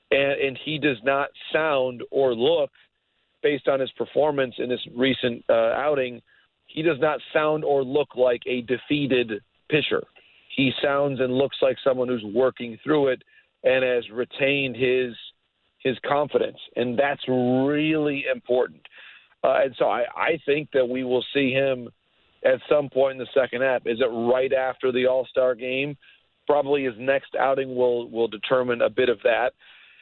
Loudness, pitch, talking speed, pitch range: -23 LUFS, 130 Hz, 170 wpm, 125-140 Hz